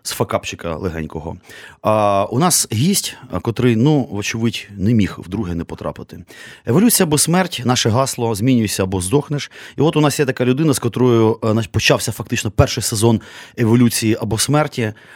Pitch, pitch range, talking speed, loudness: 115 Hz, 105-135 Hz, 155 wpm, -17 LUFS